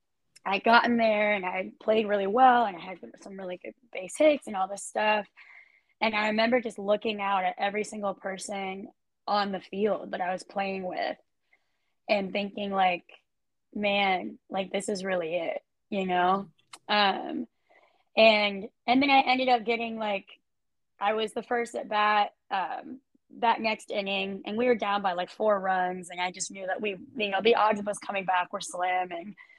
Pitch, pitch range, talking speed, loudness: 205 Hz, 190-230 Hz, 190 wpm, -27 LUFS